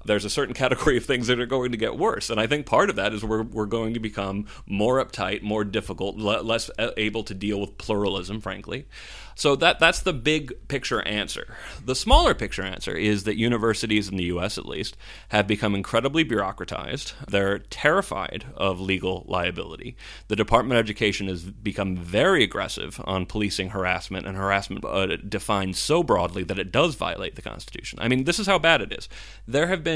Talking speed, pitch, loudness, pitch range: 195 wpm, 105 Hz, -24 LUFS, 100-115 Hz